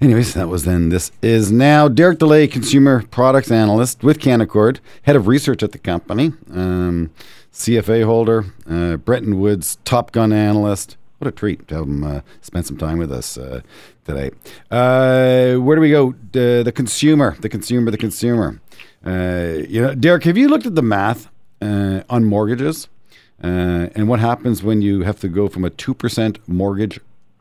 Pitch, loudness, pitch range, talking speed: 115 Hz, -16 LUFS, 95-130 Hz, 180 wpm